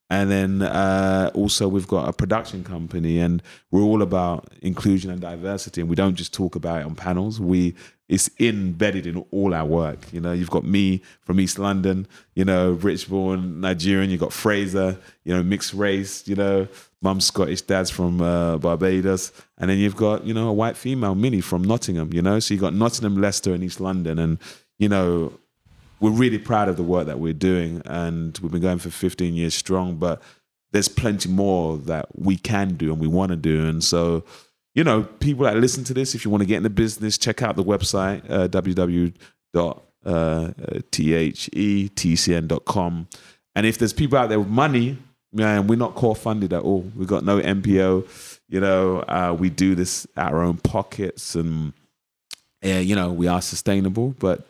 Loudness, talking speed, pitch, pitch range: -22 LUFS, 190 wpm, 95 Hz, 85-100 Hz